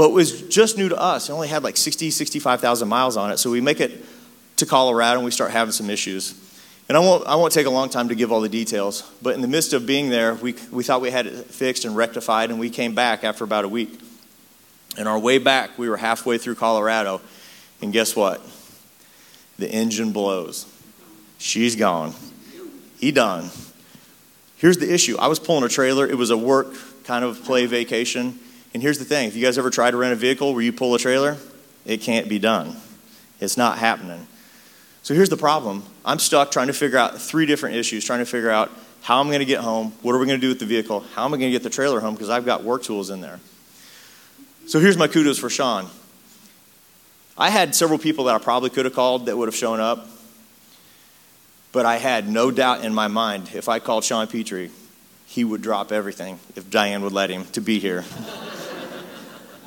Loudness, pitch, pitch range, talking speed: -20 LUFS, 120 Hz, 110-140 Hz, 220 wpm